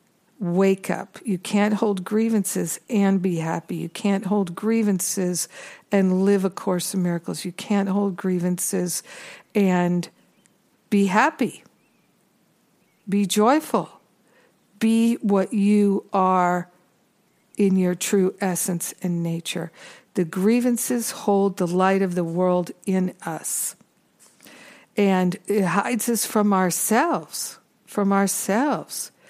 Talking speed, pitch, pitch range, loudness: 115 wpm, 195 Hz, 180-210 Hz, -22 LUFS